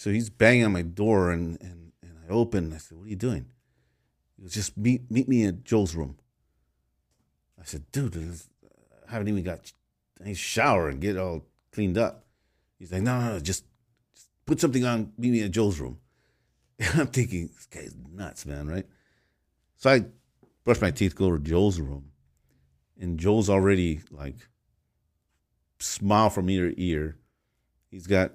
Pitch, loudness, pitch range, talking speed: 95 Hz, -26 LUFS, 75-110 Hz, 180 wpm